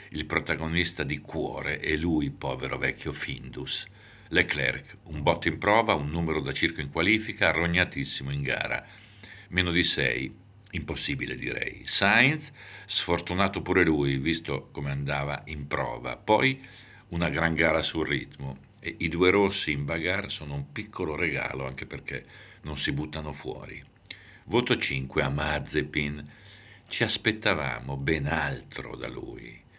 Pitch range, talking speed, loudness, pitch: 75-100 Hz, 140 wpm, -27 LUFS, 85 Hz